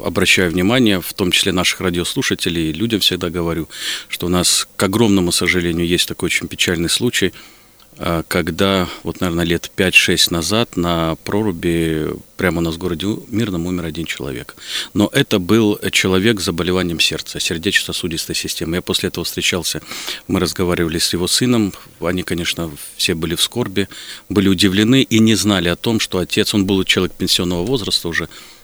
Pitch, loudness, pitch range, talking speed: 90 Hz, -17 LUFS, 85-105 Hz, 165 wpm